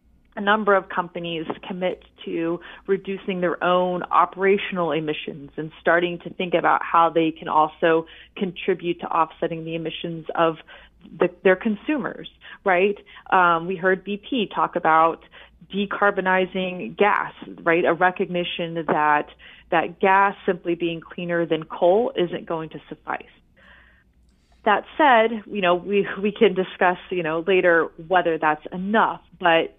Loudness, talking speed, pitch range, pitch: -22 LUFS, 135 wpm, 165-195 Hz, 175 Hz